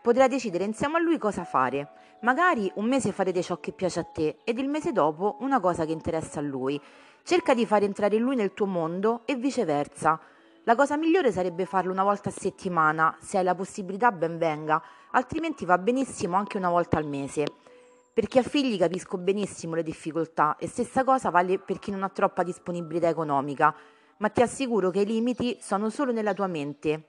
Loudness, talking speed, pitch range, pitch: -26 LUFS, 195 wpm, 165-240 Hz, 195 Hz